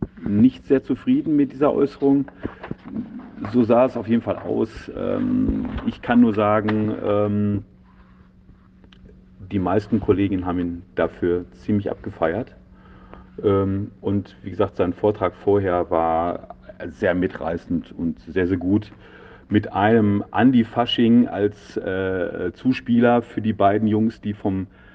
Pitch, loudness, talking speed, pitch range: 105 Hz, -21 LUFS, 120 wpm, 95-120 Hz